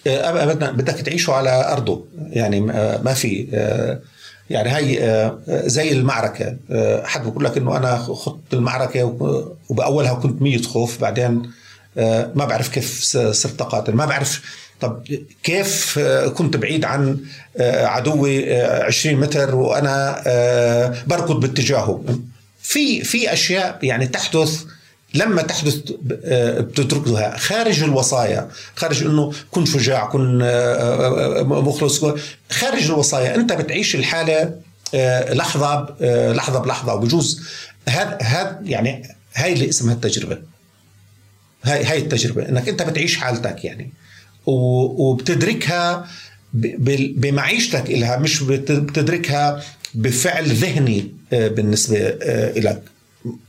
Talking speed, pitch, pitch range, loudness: 105 wpm, 135 Hz, 120-150 Hz, -18 LUFS